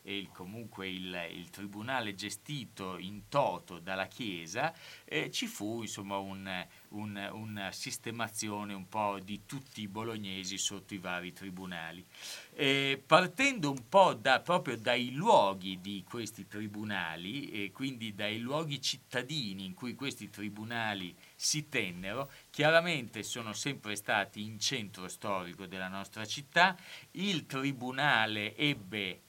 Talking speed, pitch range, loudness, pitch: 130 wpm, 95-135 Hz, -34 LUFS, 105 Hz